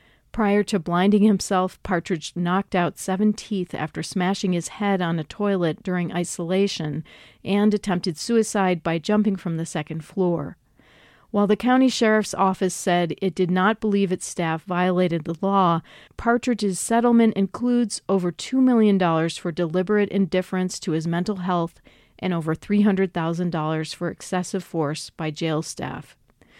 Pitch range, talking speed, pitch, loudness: 170-205 Hz, 145 wpm, 185 Hz, -23 LUFS